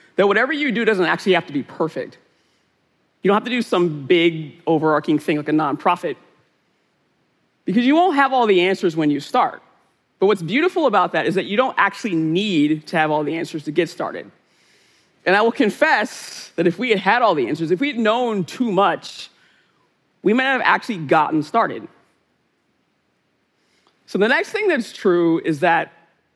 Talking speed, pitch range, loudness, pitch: 190 wpm, 160-235 Hz, -19 LUFS, 180 Hz